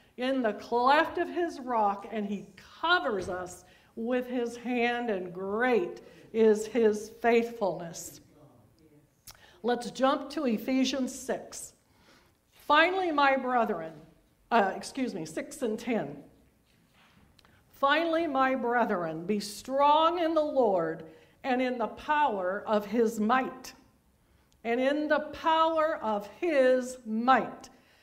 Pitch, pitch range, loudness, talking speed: 240 Hz, 205-270 Hz, -28 LUFS, 115 wpm